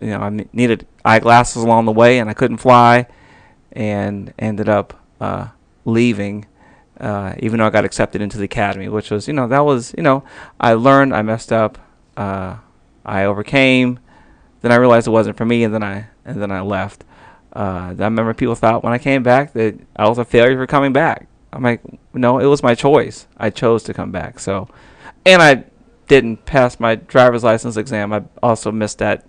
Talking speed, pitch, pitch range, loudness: 200 wpm, 115 Hz, 105-125 Hz, -15 LUFS